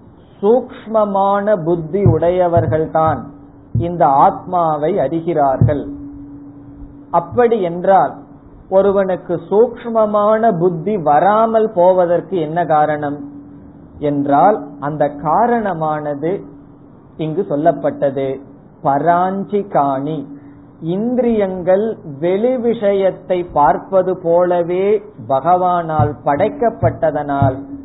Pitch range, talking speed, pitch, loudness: 145-195 Hz, 60 wpm, 170 Hz, -15 LUFS